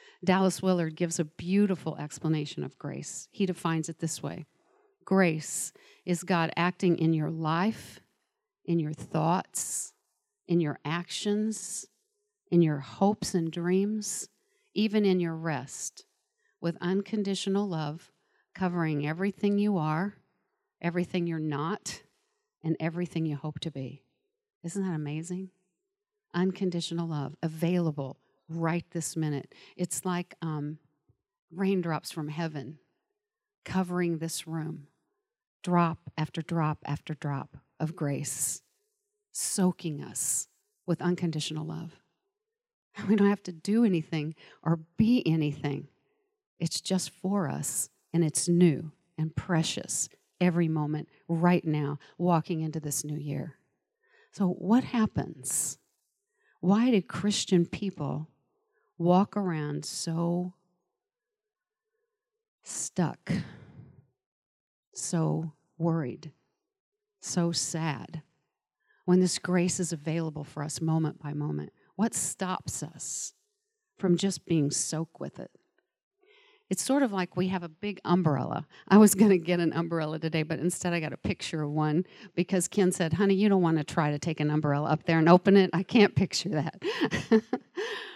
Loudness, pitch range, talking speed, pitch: -29 LUFS, 160-200 Hz, 130 wpm, 175 Hz